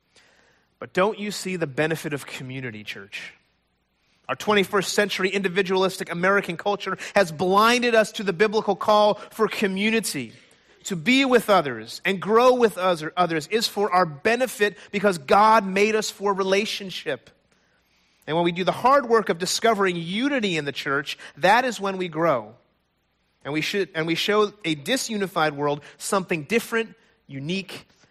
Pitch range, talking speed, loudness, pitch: 165-215 Hz, 160 wpm, -22 LUFS, 195 Hz